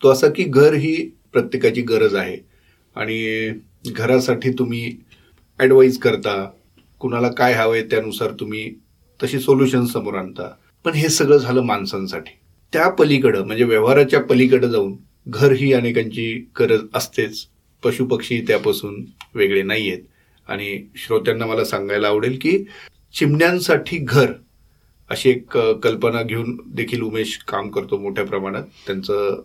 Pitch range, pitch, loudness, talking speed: 110-155 Hz, 125 Hz, -18 LUFS, 130 wpm